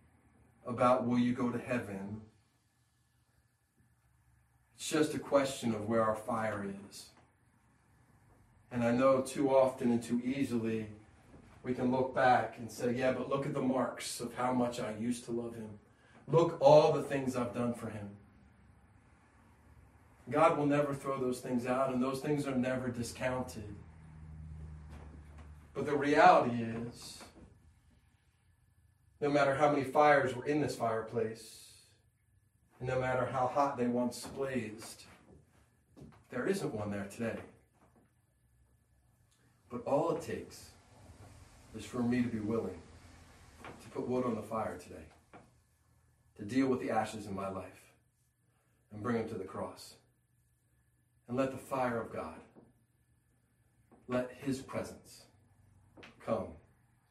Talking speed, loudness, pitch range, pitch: 140 wpm, -33 LUFS, 105-125 Hz, 115 Hz